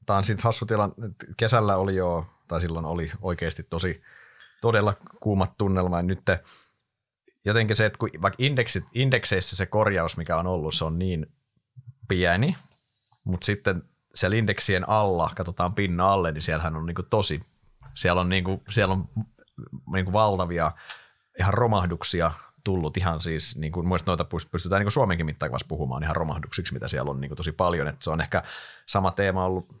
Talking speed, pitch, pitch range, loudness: 170 wpm, 95 Hz, 85-110 Hz, -25 LUFS